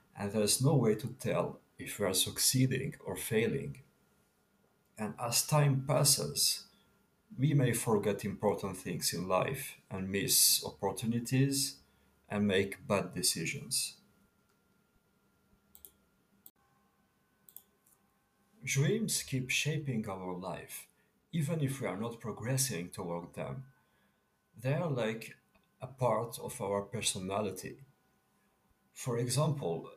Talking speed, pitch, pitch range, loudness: 110 wpm, 115 Hz, 95-135 Hz, -33 LUFS